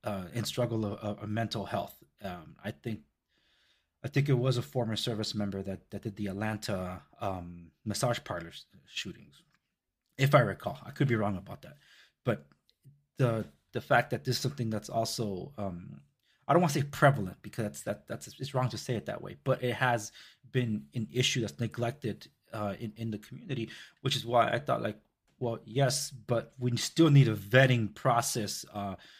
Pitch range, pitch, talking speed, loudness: 105-130 Hz, 115 Hz, 190 wpm, -32 LUFS